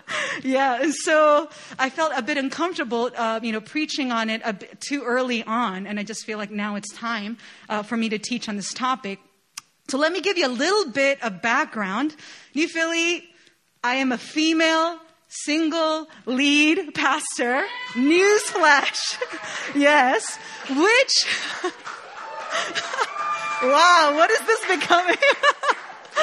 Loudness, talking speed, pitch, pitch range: -21 LUFS, 140 wpm, 285 Hz, 235-325 Hz